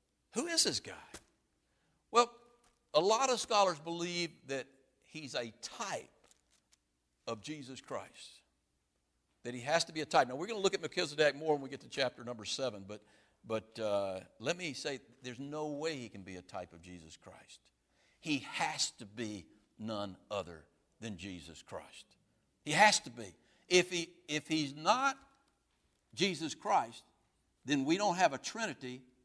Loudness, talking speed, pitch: -35 LUFS, 170 wpm, 135 Hz